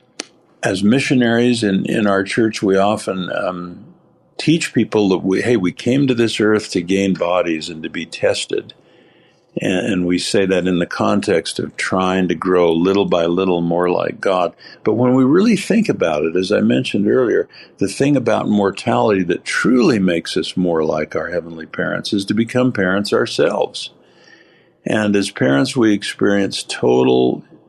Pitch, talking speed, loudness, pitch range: 100 Hz, 170 wpm, -17 LUFS, 90-120 Hz